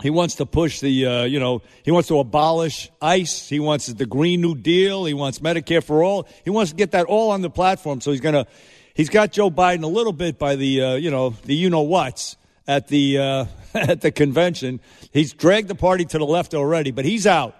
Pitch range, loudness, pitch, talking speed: 140-175 Hz, -20 LUFS, 155 Hz, 235 wpm